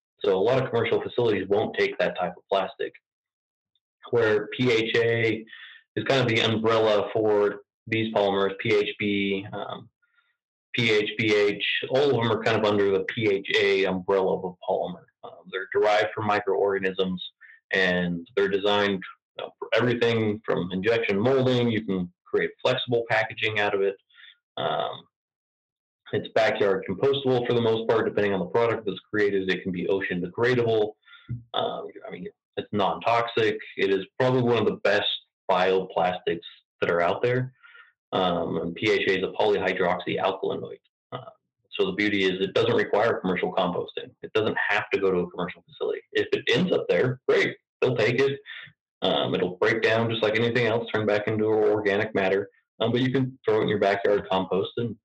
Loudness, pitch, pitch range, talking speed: -25 LUFS, 115 Hz, 100-140 Hz, 170 wpm